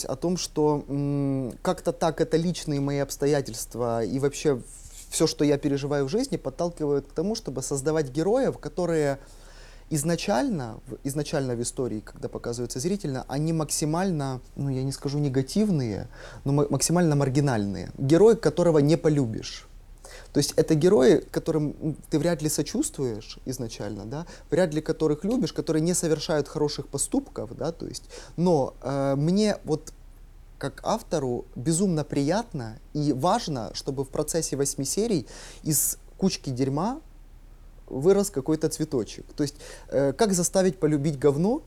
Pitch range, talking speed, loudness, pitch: 135-165 Hz, 140 wpm, -26 LUFS, 150 Hz